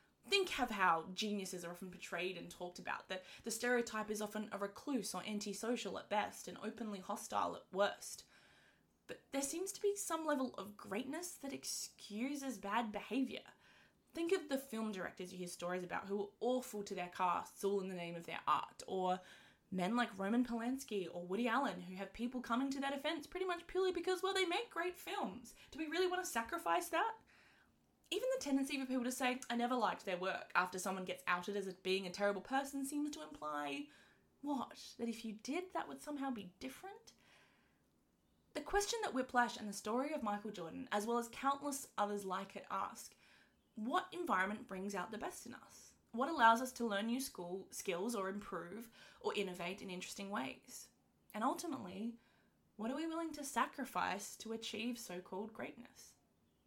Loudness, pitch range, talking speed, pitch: -41 LUFS, 190-275 Hz, 190 wpm, 225 Hz